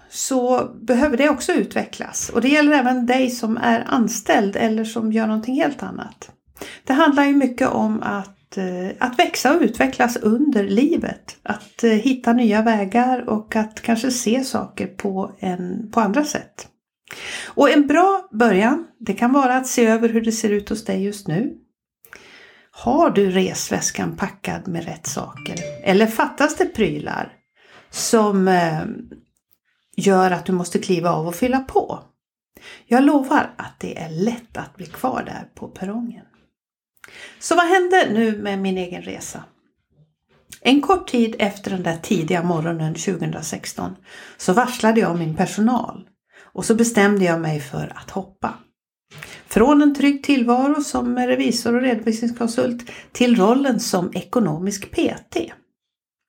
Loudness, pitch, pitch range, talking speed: -19 LUFS, 230 Hz, 195-255 Hz, 150 wpm